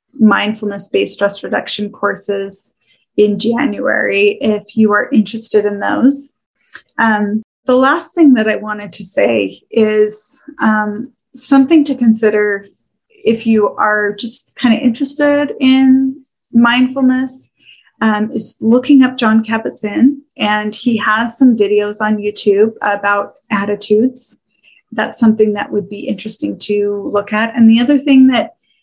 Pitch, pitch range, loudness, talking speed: 220 Hz, 210-260 Hz, -13 LUFS, 135 wpm